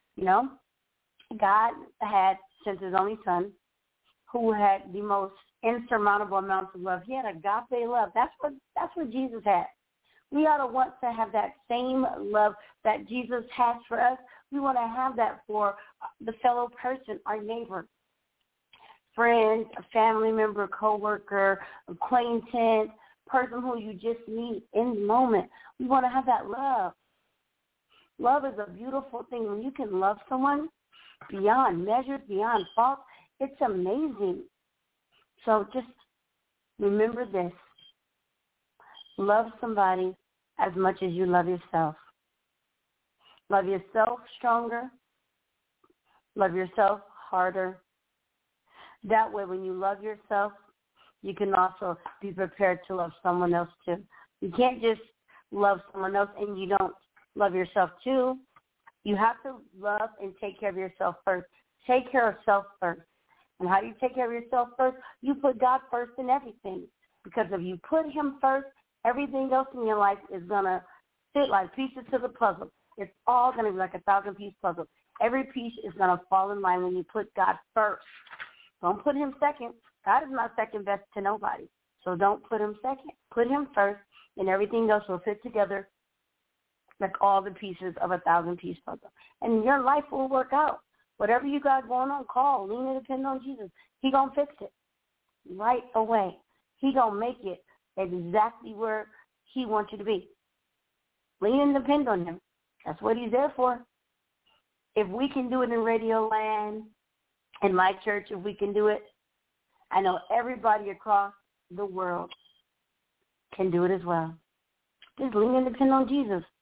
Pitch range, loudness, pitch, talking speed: 195-255 Hz, -28 LUFS, 220 Hz, 165 wpm